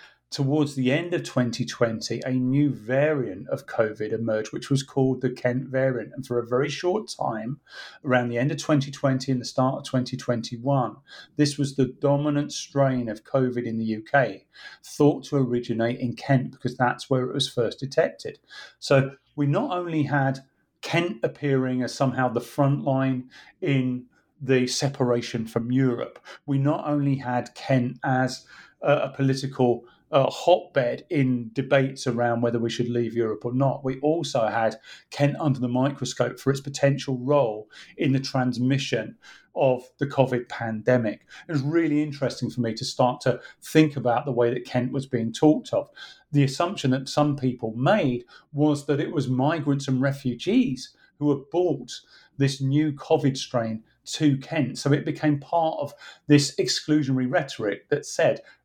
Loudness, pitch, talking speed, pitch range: -25 LUFS, 135 Hz, 165 wpm, 125-145 Hz